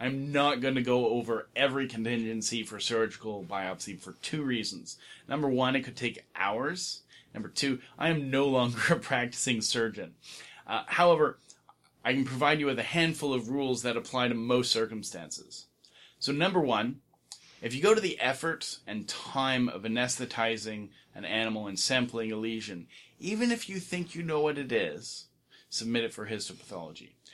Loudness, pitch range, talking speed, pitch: -30 LUFS, 115-140 Hz, 170 wpm, 125 Hz